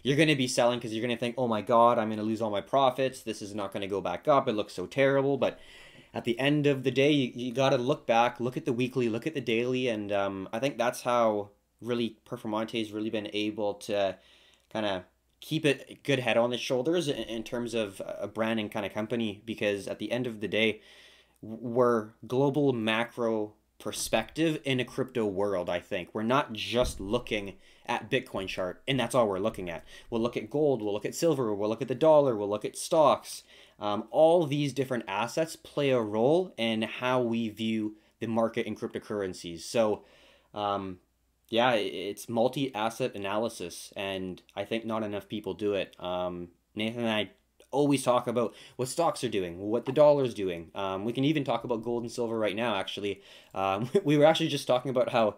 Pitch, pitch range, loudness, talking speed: 115 Hz, 105-130 Hz, -29 LUFS, 210 wpm